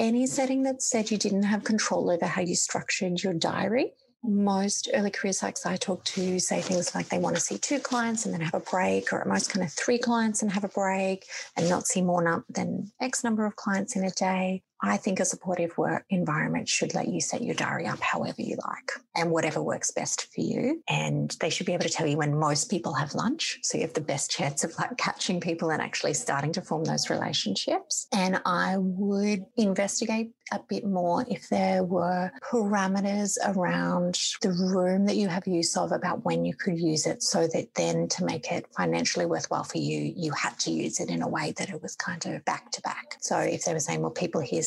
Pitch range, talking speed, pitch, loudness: 175-210 Hz, 225 wpm, 190 Hz, -28 LUFS